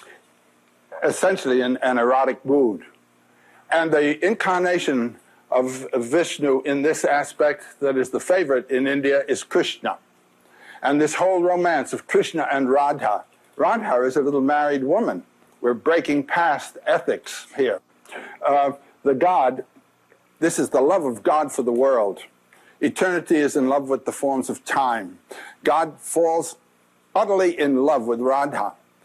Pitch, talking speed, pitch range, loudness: 140 Hz, 140 wpm, 125-165 Hz, -21 LUFS